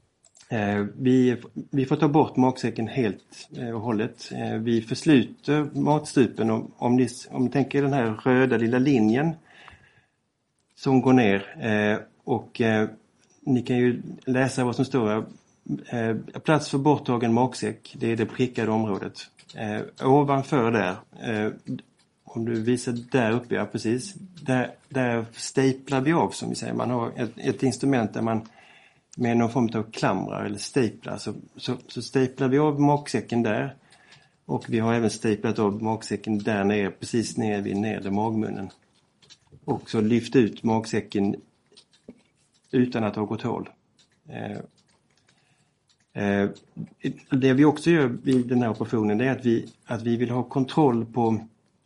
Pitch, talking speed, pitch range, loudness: 120 Hz, 145 wpm, 110-130 Hz, -25 LUFS